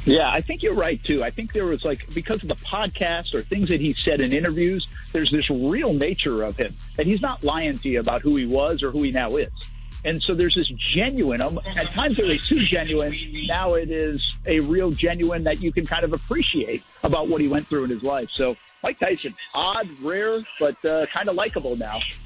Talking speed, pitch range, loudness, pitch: 230 wpm, 145-175 Hz, -23 LUFS, 160 Hz